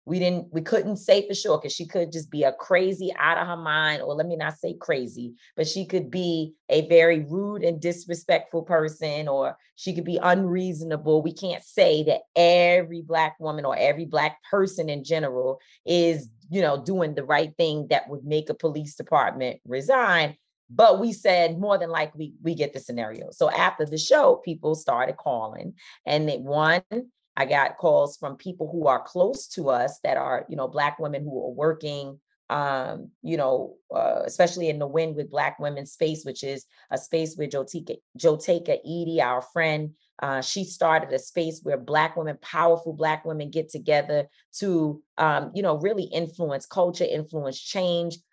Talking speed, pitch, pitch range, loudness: 185 wpm, 160 Hz, 150-175 Hz, -24 LUFS